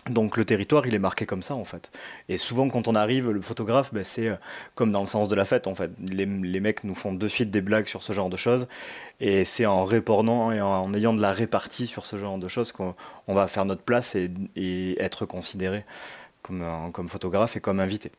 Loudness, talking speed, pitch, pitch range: -26 LUFS, 240 wpm, 100 Hz, 95-115 Hz